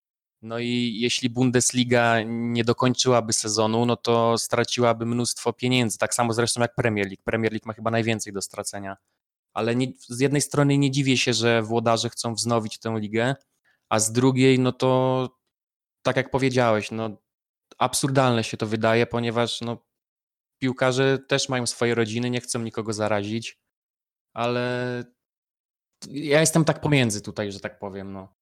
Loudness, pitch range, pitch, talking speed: -23 LUFS, 115-125 Hz, 120 Hz, 150 wpm